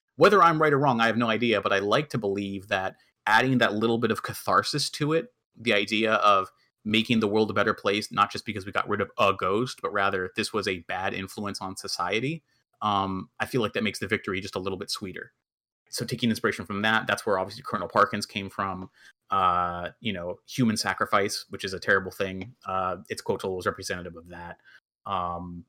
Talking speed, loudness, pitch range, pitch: 215 wpm, -26 LUFS, 95-120 Hz, 110 Hz